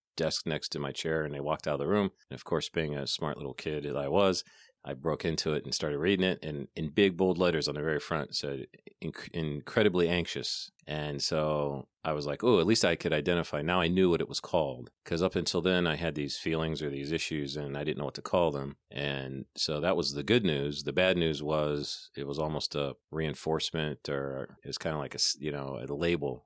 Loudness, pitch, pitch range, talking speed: -31 LUFS, 75 Hz, 70-85 Hz, 245 wpm